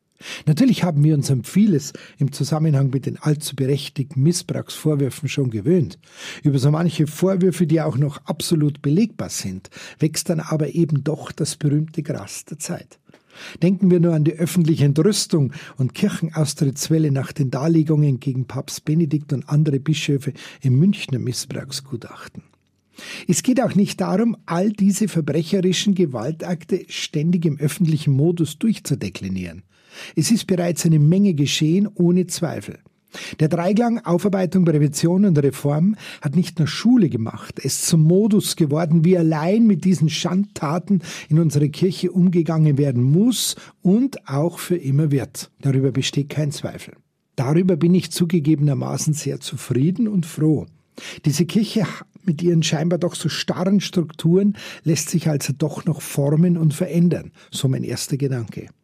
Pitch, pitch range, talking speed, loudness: 160 Hz, 145-180 Hz, 145 wpm, -20 LUFS